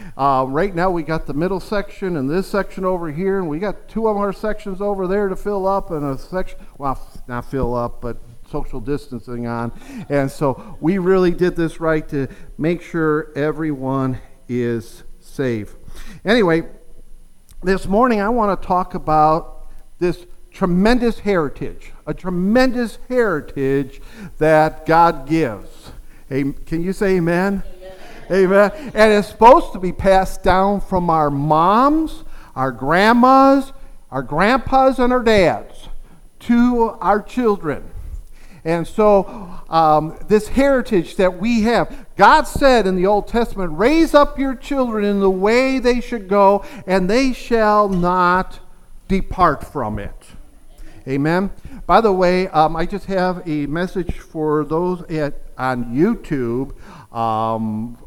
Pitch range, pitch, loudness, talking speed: 150-205 Hz, 180 Hz, -17 LUFS, 140 wpm